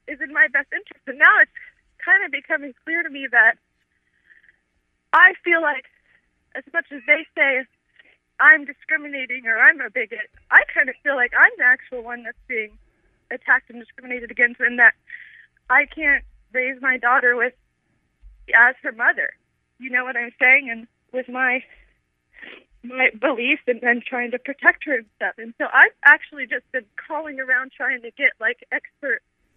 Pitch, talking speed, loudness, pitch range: 265 Hz, 175 wpm, -18 LUFS, 245-300 Hz